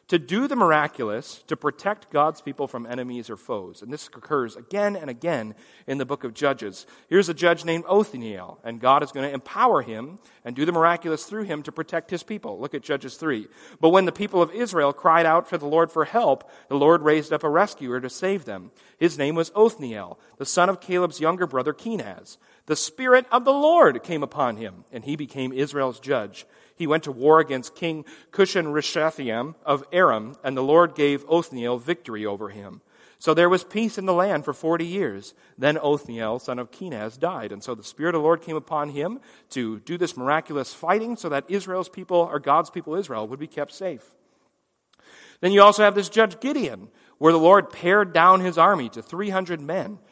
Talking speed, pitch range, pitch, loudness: 210 wpm, 140-185 Hz, 160 Hz, -22 LUFS